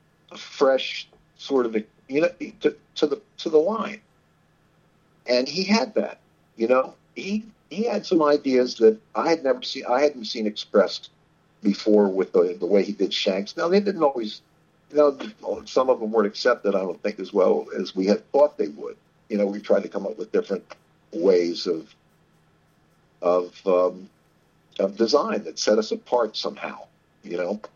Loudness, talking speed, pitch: -23 LUFS, 180 wpm, 145 Hz